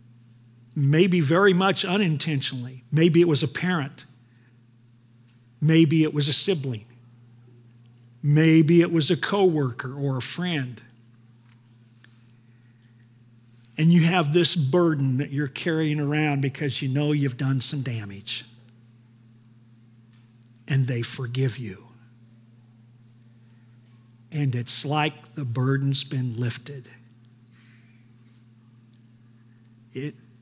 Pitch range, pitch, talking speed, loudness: 115-145 Hz, 120 Hz, 100 wpm, -23 LUFS